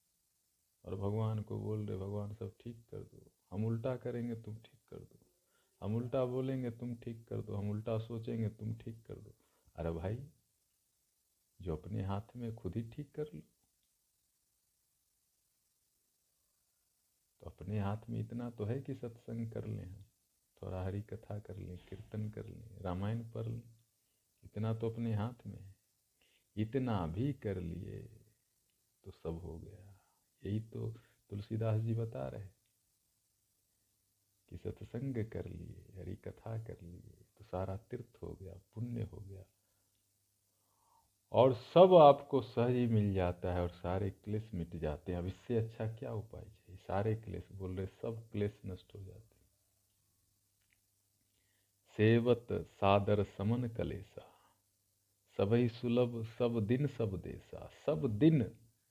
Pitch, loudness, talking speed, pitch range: 105 Hz, -37 LUFS, 145 wpm, 100-115 Hz